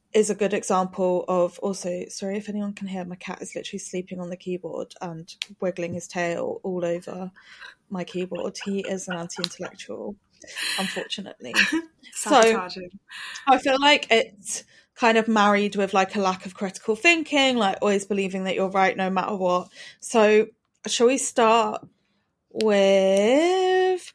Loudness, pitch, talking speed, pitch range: -23 LUFS, 195 Hz, 155 wpm, 185-225 Hz